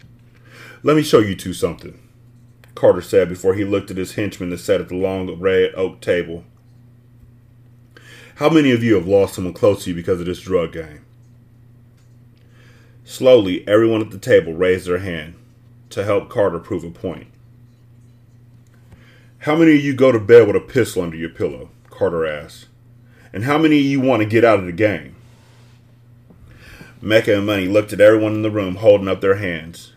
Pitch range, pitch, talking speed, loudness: 100-120 Hz, 120 Hz, 180 wpm, -17 LUFS